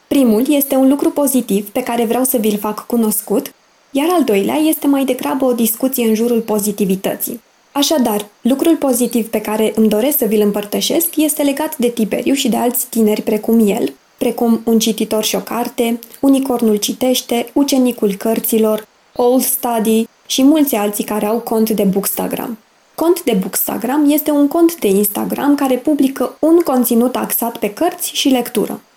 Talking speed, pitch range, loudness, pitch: 165 wpm, 220-275 Hz, -15 LUFS, 240 Hz